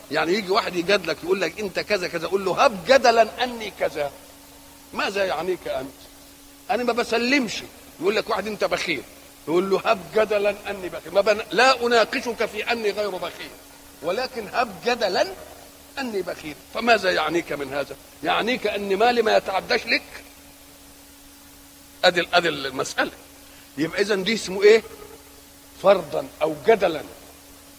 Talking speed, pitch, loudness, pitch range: 140 wpm, 205 Hz, -22 LUFS, 175-230 Hz